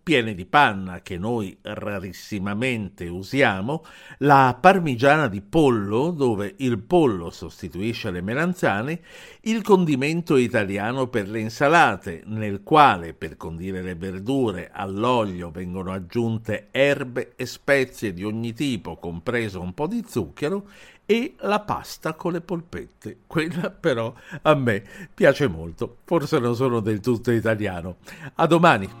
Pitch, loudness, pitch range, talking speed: 115 Hz, -22 LUFS, 95-140 Hz, 130 wpm